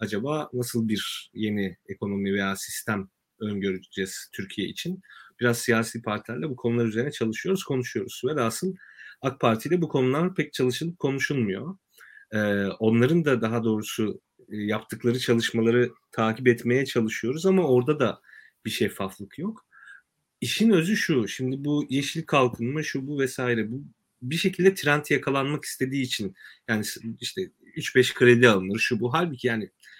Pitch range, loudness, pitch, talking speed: 110-145 Hz, -26 LUFS, 125 Hz, 140 wpm